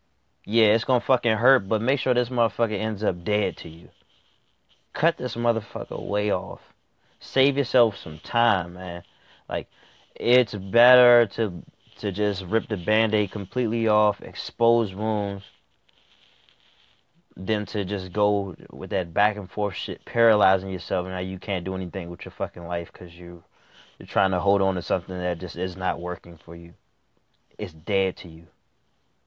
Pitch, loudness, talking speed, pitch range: 105 Hz, -24 LUFS, 165 wpm, 90-115 Hz